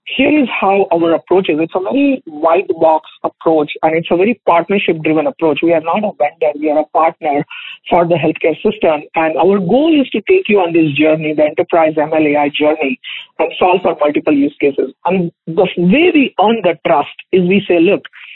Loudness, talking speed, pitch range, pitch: -13 LUFS, 205 wpm, 155-195 Hz, 170 Hz